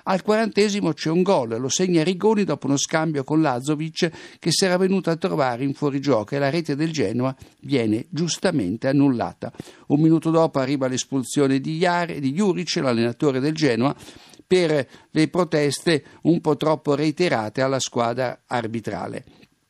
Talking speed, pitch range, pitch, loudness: 155 wpm, 135-170 Hz, 150 Hz, -22 LUFS